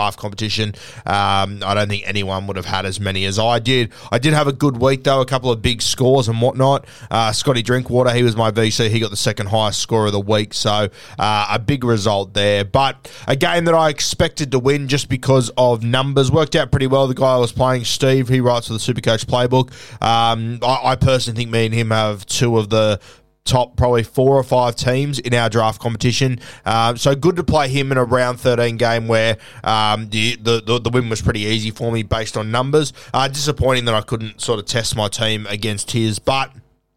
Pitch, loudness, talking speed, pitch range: 120 Hz, -17 LUFS, 225 wpm, 110-130 Hz